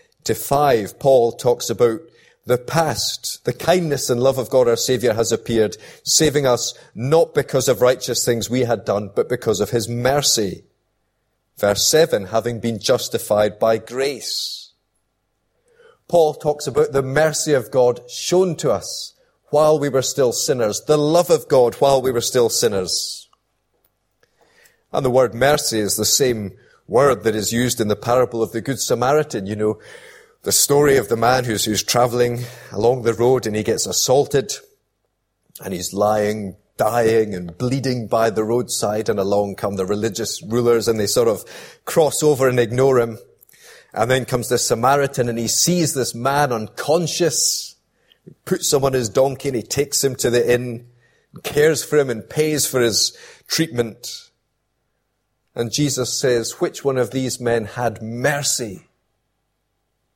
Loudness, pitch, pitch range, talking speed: -18 LUFS, 125 Hz, 115-145 Hz, 165 wpm